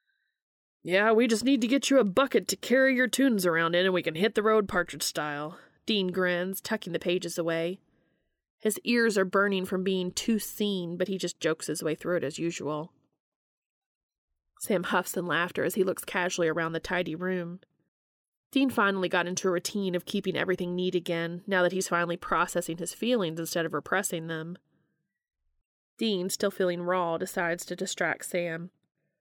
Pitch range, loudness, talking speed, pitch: 170-200 Hz, -28 LUFS, 185 wpm, 180 Hz